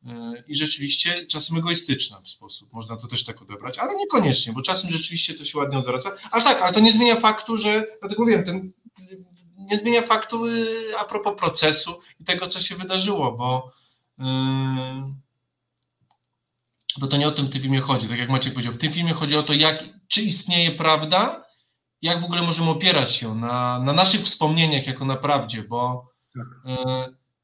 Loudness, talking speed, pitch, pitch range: -20 LUFS, 185 wpm, 155 Hz, 130-185 Hz